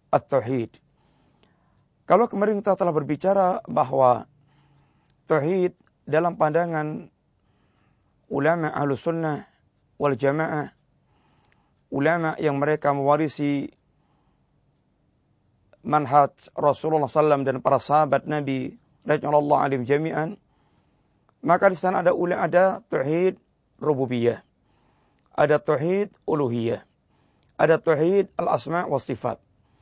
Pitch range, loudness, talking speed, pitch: 140-165 Hz, -23 LUFS, 90 wpm, 150 Hz